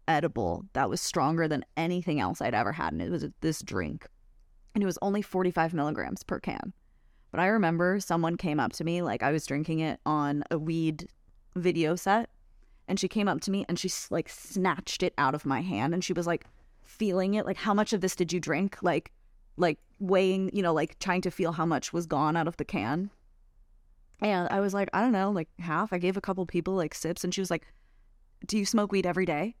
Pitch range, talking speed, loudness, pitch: 160-195 Hz, 230 wpm, -29 LUFS, 180 Hz